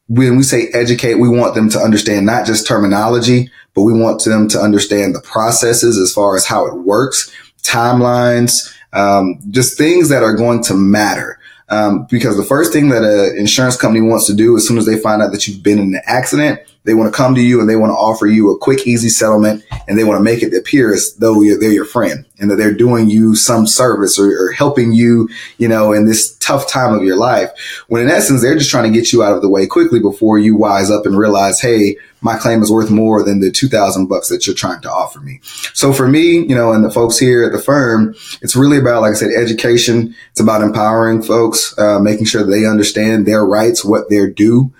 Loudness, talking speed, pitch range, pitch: -11 LUFS, 240 wpm, 105-120 Hz, 110 Hz